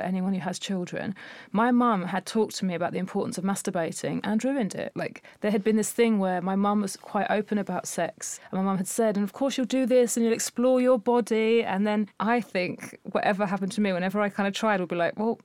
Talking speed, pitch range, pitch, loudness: 255 wpm, 190-235 Hz, 210 Hz, -26 LUFS